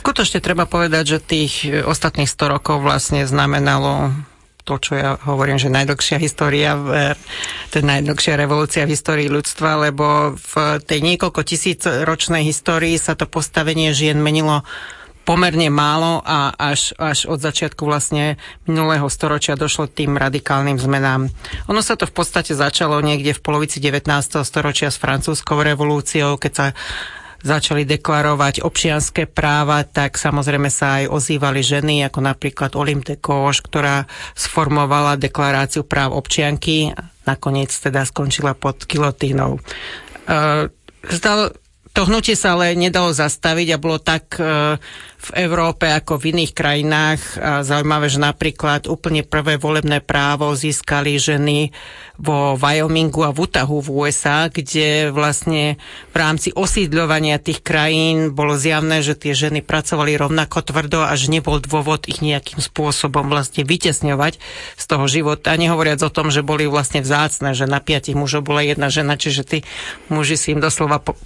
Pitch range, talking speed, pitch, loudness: 145-160 Hz, 145 wpm, 150 Hz, -17 LUFS